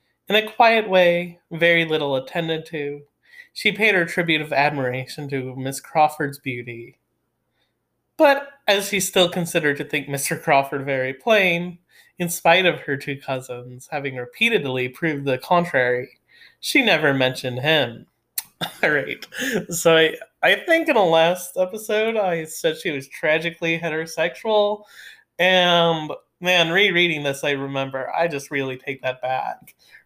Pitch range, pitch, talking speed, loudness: 140-180 Hz, 160 Hz, 145 wpm, -20 LUFS